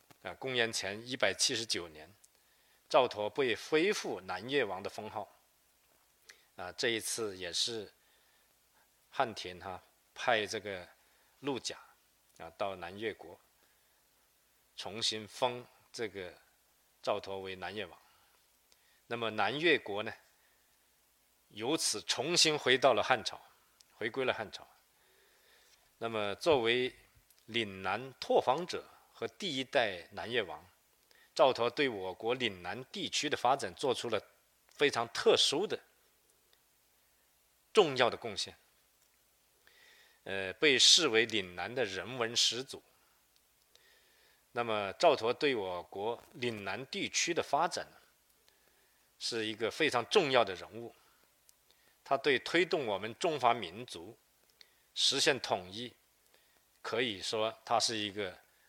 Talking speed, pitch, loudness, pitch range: 165 characters per minute, 115 Hz, -33 LUFS, 105-170 Hz